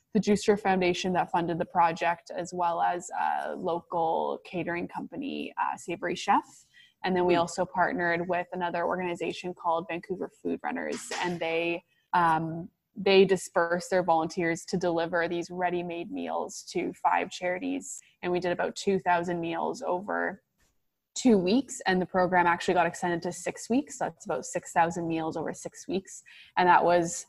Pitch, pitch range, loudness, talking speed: 175 Hz, 170-185 Hz, -28 LUFS, 160 wpm